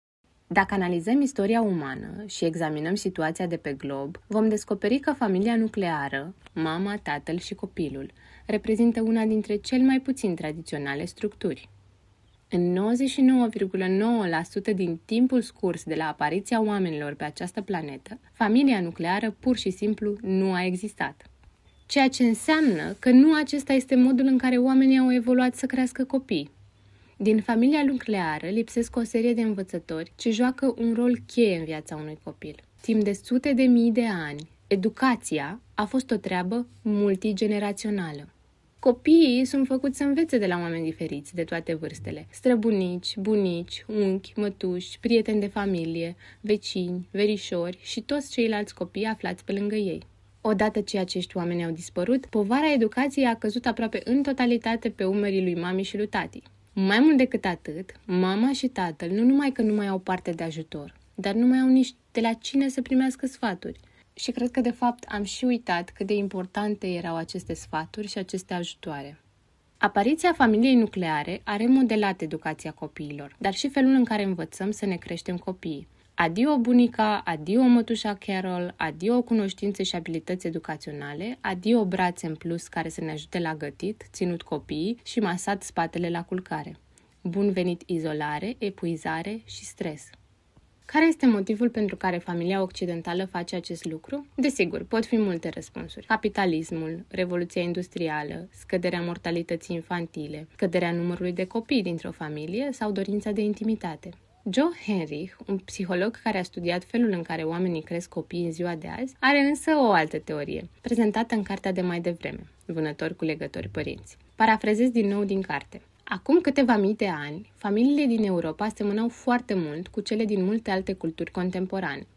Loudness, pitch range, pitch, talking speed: -26 LUFS, 170-230 Hz, 200 Hz, 160 wpm